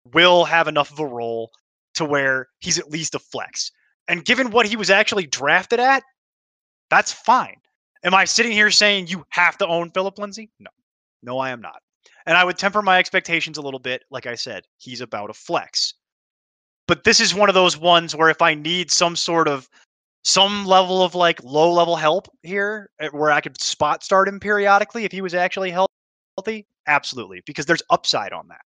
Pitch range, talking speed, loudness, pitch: 150-200 Hz, 200 wpm, -18 LUFS, 175 Hz